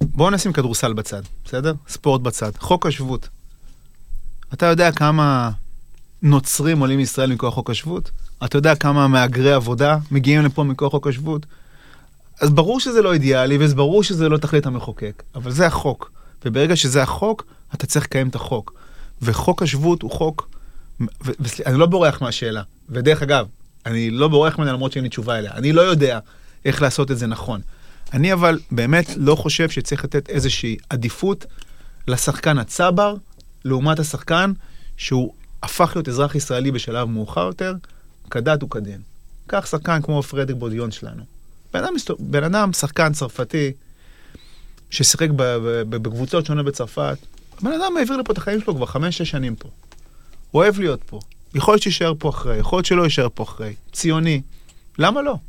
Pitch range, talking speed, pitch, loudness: 120-160 Hz, 160 wpm, 140 Hz, -19 LUFS